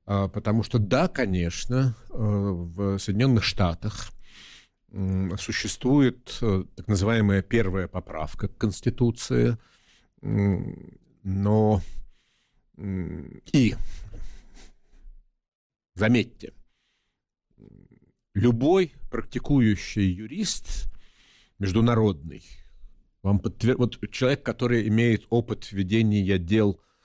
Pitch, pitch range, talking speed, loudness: 105 Hz, 95-115 Hz, 65 wpm, -25 LUFS